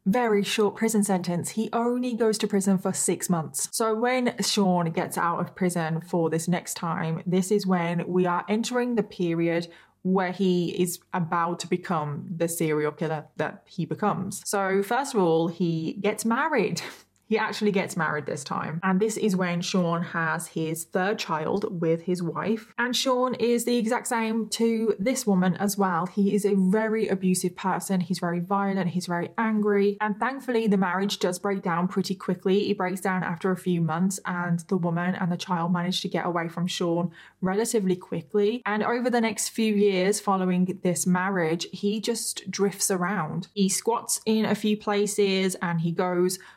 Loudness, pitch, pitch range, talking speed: -26 LUFS, 190 Hz, 175-210 Hz, 185 wpm